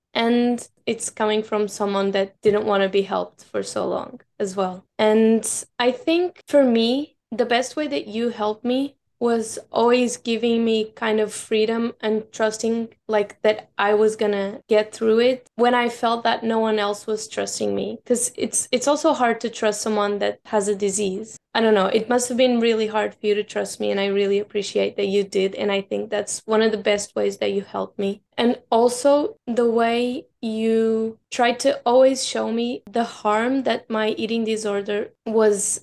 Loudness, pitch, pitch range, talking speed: -22 LUFS, 225 Hz, 210-240 Hz, 200 wpm